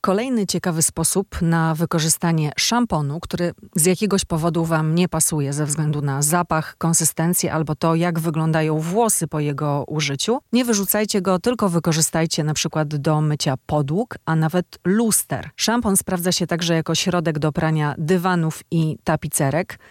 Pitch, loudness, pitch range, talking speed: 165 Hz, -20 LUFS, 155-185 Hz, 150 wpm